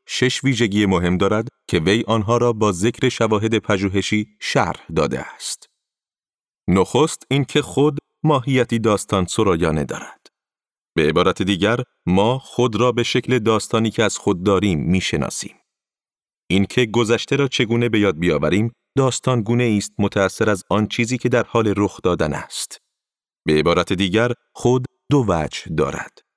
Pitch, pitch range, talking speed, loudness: 115 Hz, 100-125 Hz, 150 wpm, -19 LUFS